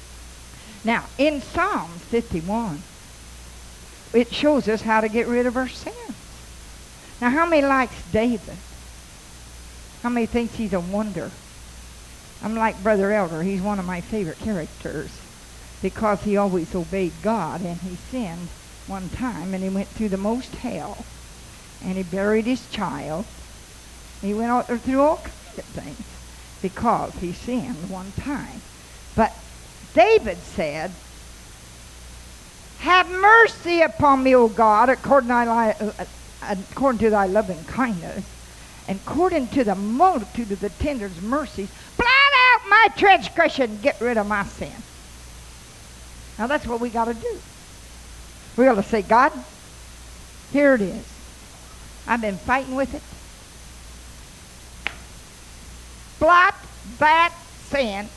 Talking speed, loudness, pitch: 135 wpm, -21 LUFS, 210 Hz